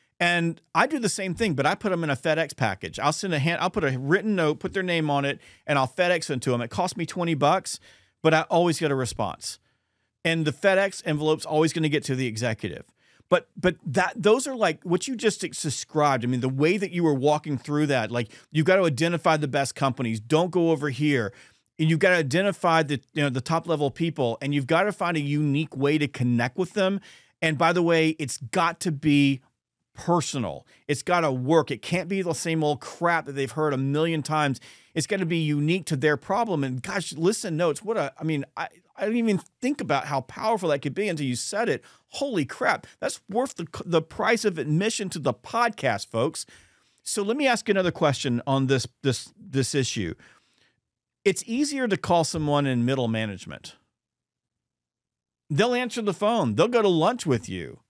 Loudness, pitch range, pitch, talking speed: -25 LUFS, 135-180 Hz, 160 Hz, 220 wpm